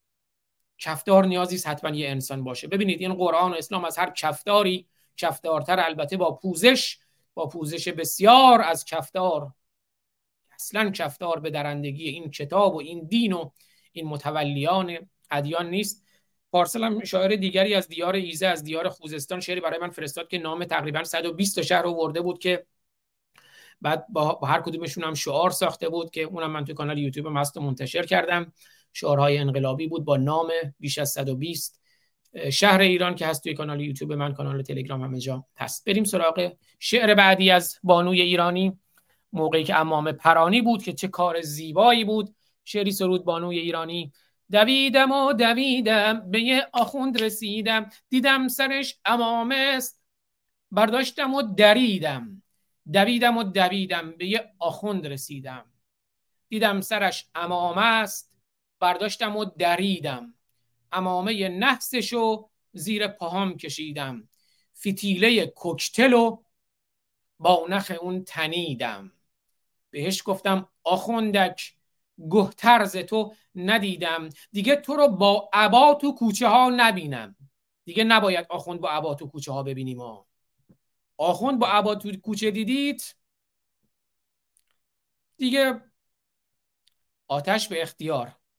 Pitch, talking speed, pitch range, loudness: 180 Hz, 135 wpm, 155-210 Hz, -23 LUFS